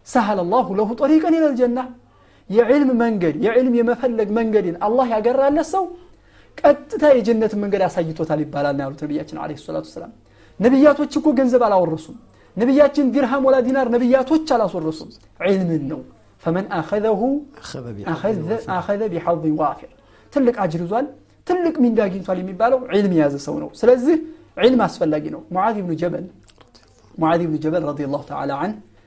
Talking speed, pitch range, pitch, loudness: 160 wpm, 170-265 Hz, 220 Hz, -19 LUFS